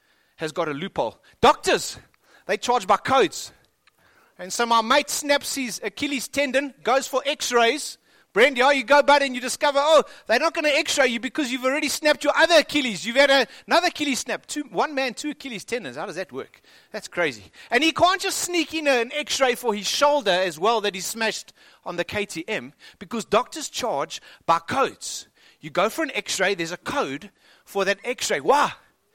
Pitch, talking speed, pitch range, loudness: 260 Hz, 205 wpm, 210-290 Hz, -22 LUFS